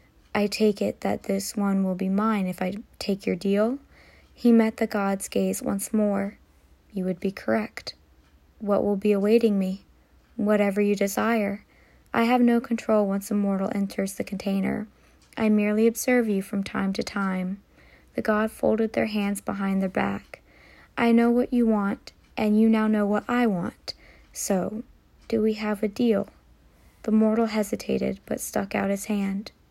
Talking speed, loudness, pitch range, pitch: 170 wpm, -25 LUFS, 195-220 Hz, 205 Hz